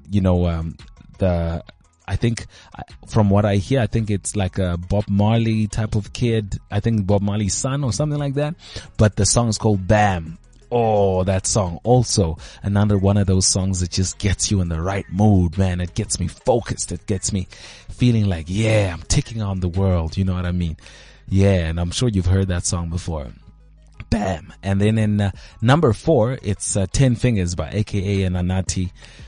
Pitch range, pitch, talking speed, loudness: 90-110 Hz, 100 Hz, 200 wpm, -20 LUFS